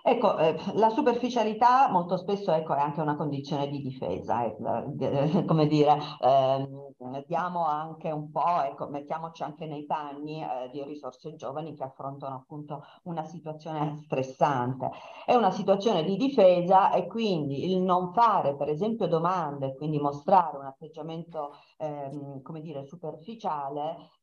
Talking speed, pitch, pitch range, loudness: 145 wpm, 155 Hz, 140-180 Hz, -27 LUFS